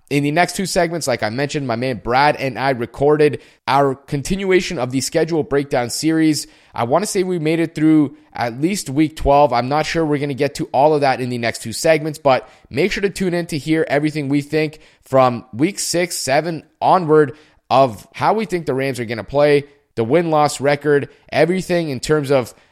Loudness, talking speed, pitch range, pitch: -18 LUFS, 220 wpm, 135-160 Hz, 150 Hz